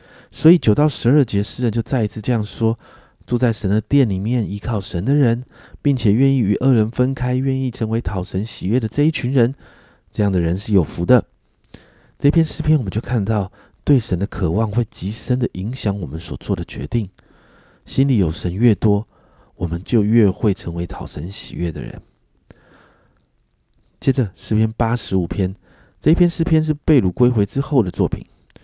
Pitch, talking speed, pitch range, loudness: 110 Hz, 265 characters per minute, 100-130 Hz, -19 LUFS